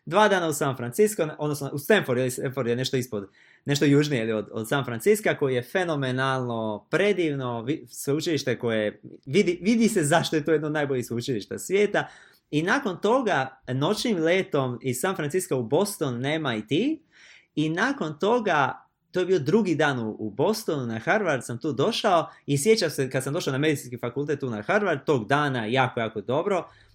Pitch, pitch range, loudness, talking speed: 140 Hz, 125-170 Hz, -25 LUFS, 185 wpm